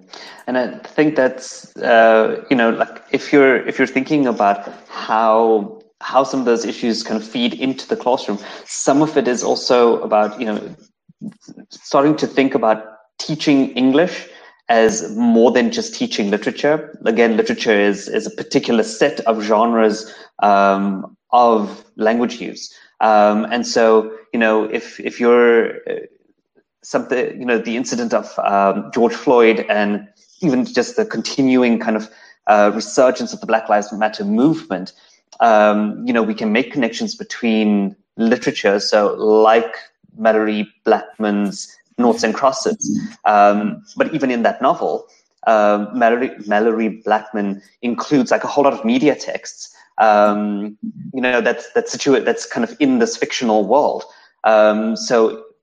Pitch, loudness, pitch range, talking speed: 115 Hz, -16 LUFS, 105-155 Hz, 150 wpm